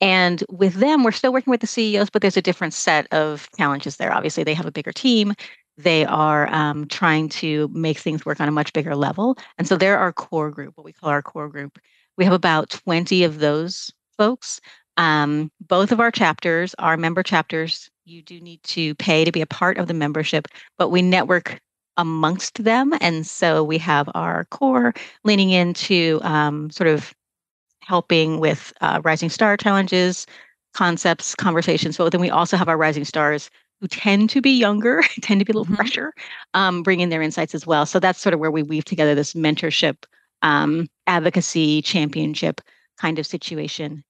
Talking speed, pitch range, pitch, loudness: 190 wpm, 155-190 Hz, 170 Hz, -19 LUFS